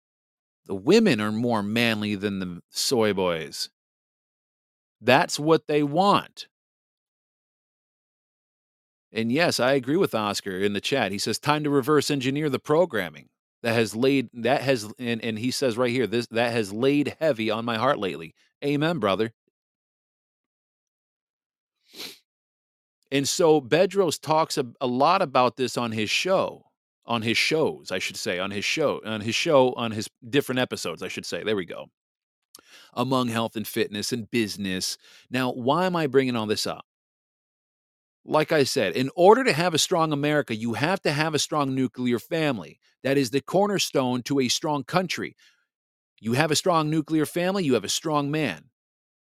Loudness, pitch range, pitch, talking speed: -24 LUFS, 115-150 Hz, 130 Hz, 165 wpm